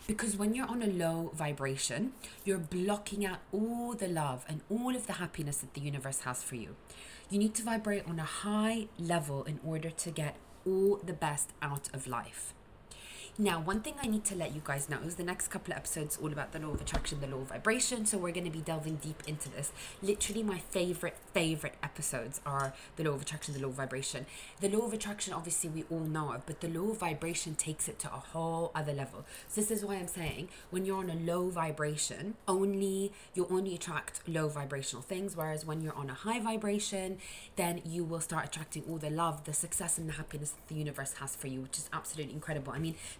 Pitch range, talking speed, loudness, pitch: 150-195 Hz, 225 wpm, -36 LUFS, 165 Hz